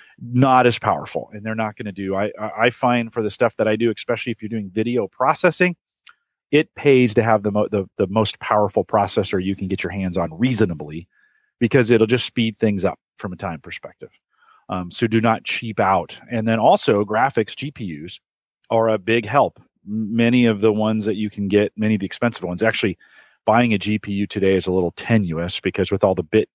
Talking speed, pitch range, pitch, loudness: 210 wpm, 100-115 Hz, 110 Hz, -20 LUFS